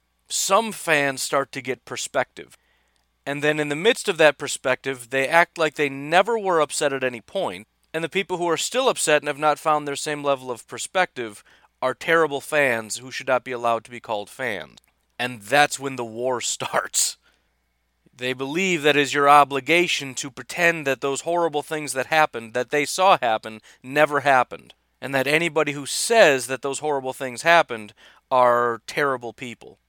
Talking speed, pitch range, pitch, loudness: 185 wpm, 125-155 Hz, 140 Hz, -22 LUFS